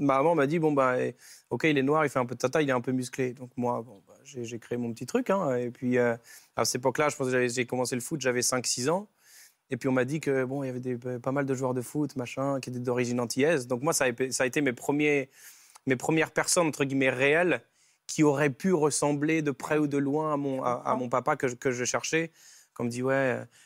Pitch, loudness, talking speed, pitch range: 130 Hz, -28 LUFS, 270 wpm, 125-150 Hz